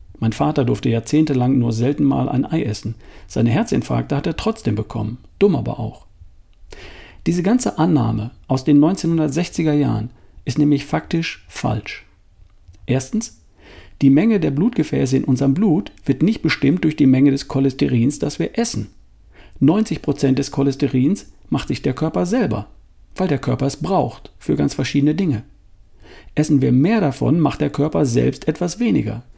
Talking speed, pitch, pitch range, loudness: 155 wpm, 135 Hz, 110-150 Hz, -19 LUFS